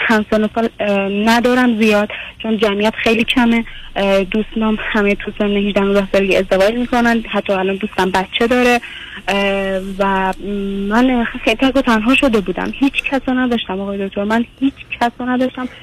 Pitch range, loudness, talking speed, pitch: 200-240 Hz, -16 LUFS, 145 wpm, 220 Hz